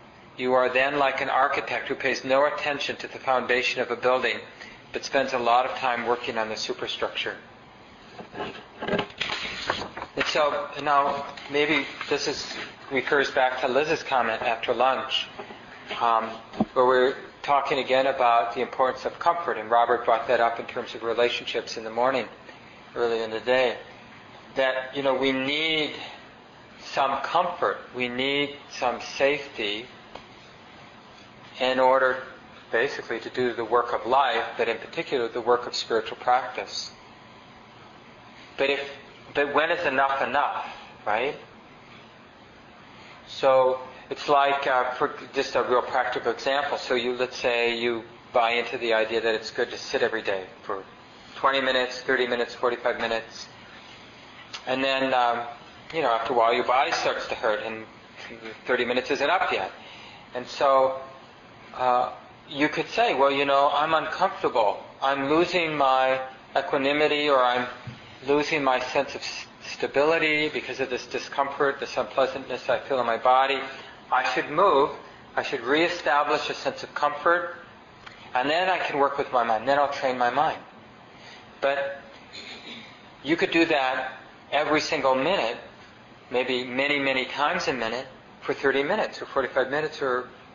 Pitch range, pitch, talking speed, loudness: 120-140 Hz, 130 Hz, 155 wpm, -25 LUFS